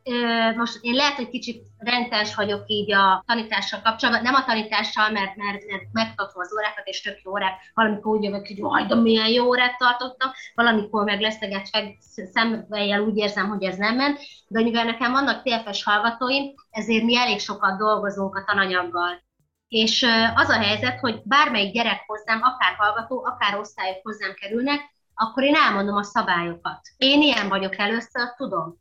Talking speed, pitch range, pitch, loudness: 165 wpm, 205-240 Hz, 220 Hz, -22 LUFS